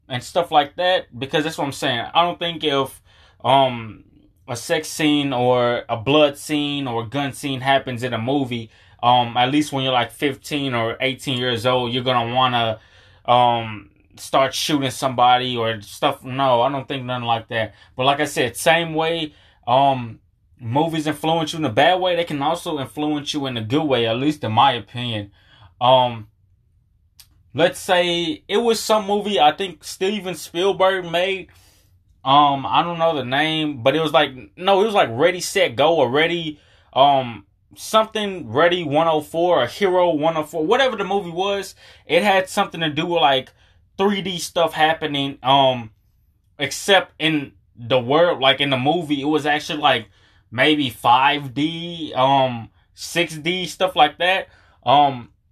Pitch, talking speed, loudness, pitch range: 140 Hz, 170 wpm, -19 LUFS, 120-165 Hz